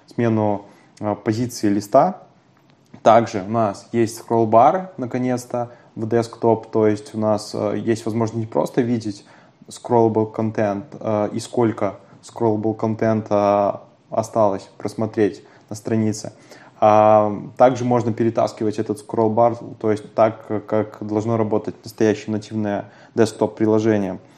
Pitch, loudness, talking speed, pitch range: 110 Hz, -20 LUFS, 120 wpm, 105-115 Hz